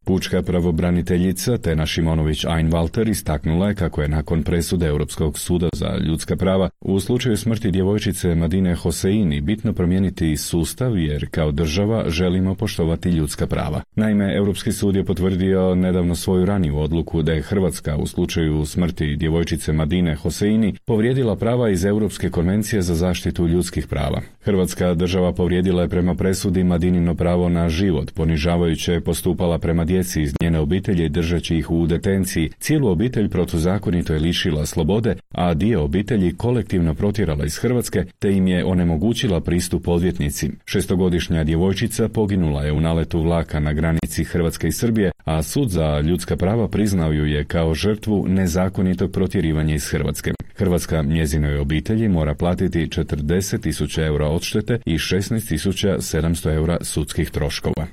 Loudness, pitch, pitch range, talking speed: -20 LUFS, 90 Hz, 80-95 Hz, 145 wpm